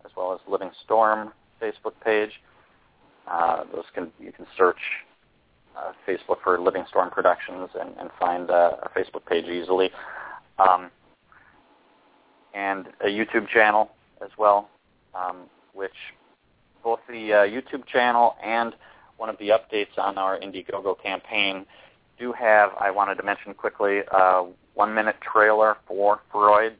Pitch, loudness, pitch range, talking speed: 105 Hz, -23 LUFS, 95-110 Hz, 140 wpm